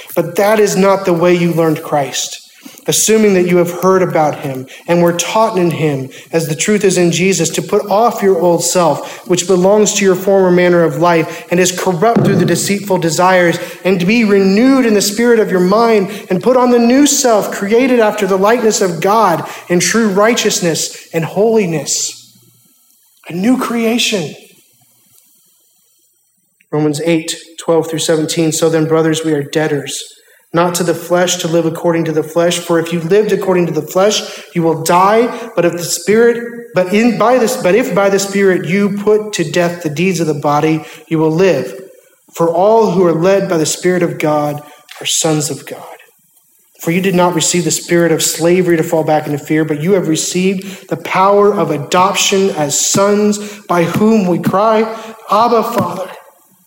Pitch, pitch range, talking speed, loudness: 180 Hz, 165-205 Hz, 190 wpm, -12 LUFS